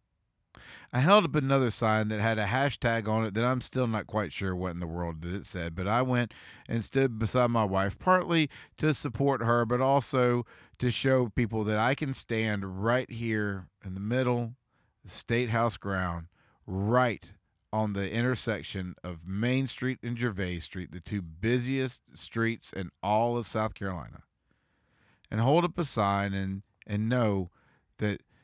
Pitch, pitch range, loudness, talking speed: 110 Hz, 100-125 Hz, -29 LUFS, 170 wpm